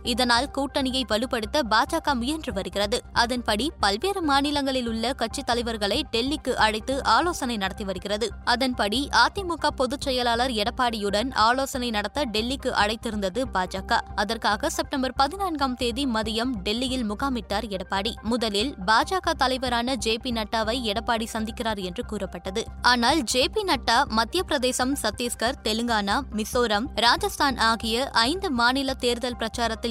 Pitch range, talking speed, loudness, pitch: 220-275 Hz, 120 wpm, -24 LUFS, 240 Hz